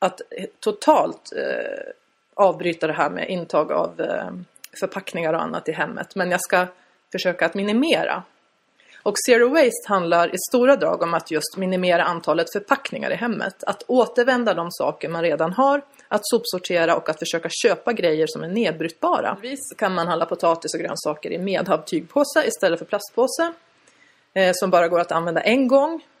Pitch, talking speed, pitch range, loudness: 190 Hz, 165 wpm, 170-265 Hz, -21 LUFS